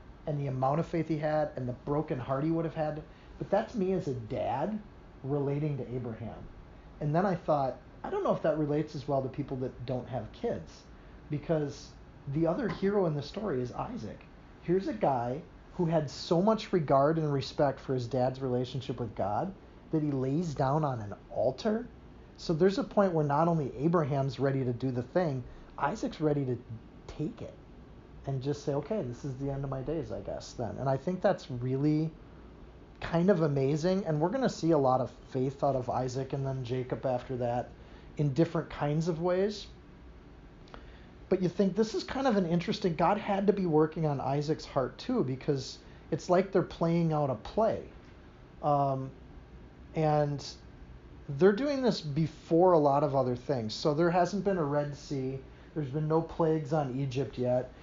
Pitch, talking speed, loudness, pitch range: 150 Hz, 195 wpm, -31 LUFS, 130-170 Hz